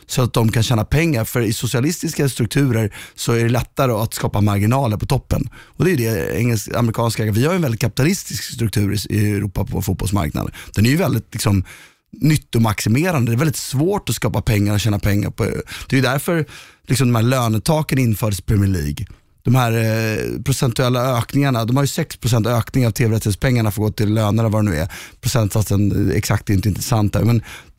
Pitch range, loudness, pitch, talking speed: 105-130 Hz, -18 LUFS, 115 Hz, 200 wpm